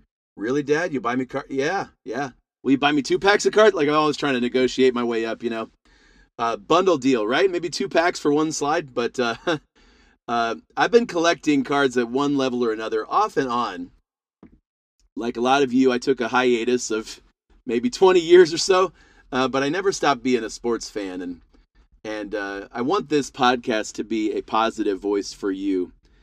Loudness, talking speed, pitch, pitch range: -22 LUFS, 210 wpm, 130 Hz, 115-155 Hz